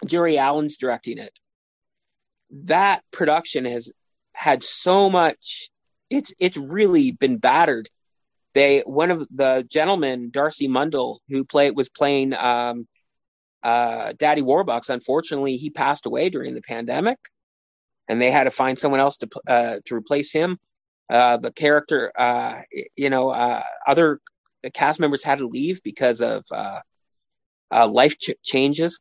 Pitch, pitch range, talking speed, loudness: 140 Hz, 125-155 Hz, 145 wpm, -21 LUFS